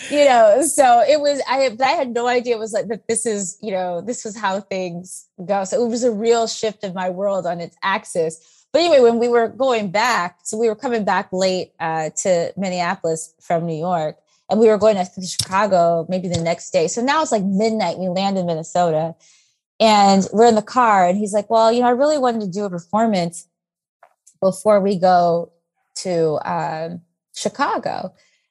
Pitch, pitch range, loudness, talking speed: 195 Hz, 175-230 Hz, -18 LUFS, 205 wpm